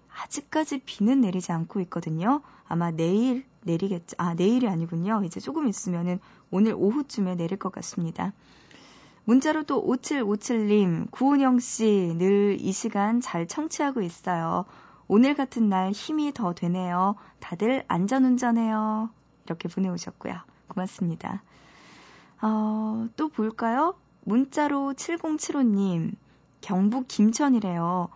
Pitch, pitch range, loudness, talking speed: 210 Hz, 180-250 Hz, -26 LUFS, 260 characters per minute